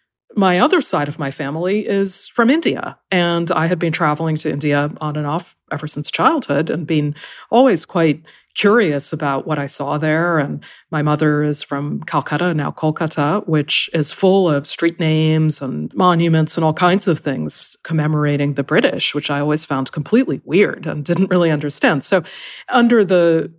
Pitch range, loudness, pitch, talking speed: 150-180 Hz, -17 LUFS, 155 Hz, 175 wpm